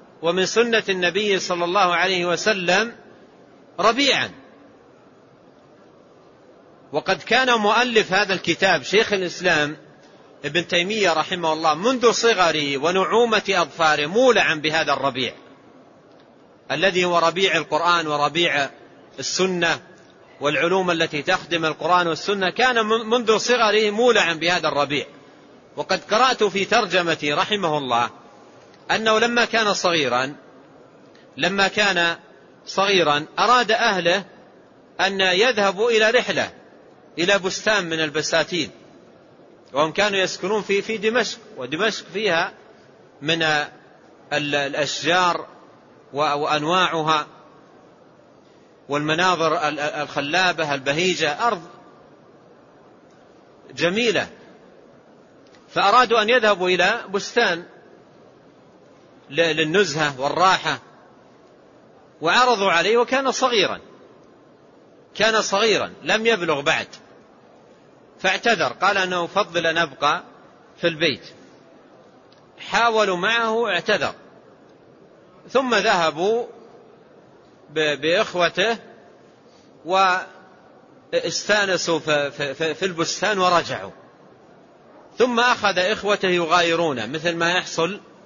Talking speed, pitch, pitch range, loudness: 85 wpm, 180 Hz, 155-210 Hz, -20 LUFS